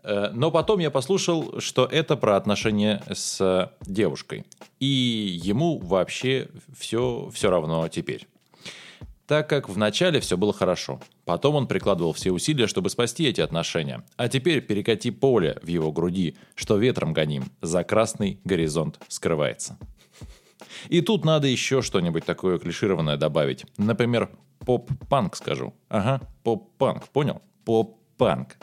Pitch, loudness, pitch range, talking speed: 110 Hz, -24 LUFS, 90-135 Hz, 130 wpm